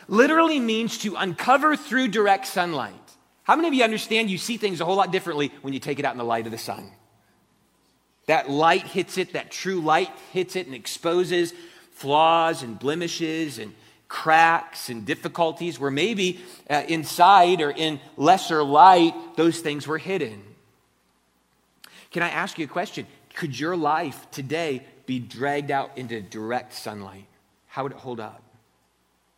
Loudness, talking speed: -22 LUFS, 165 wpm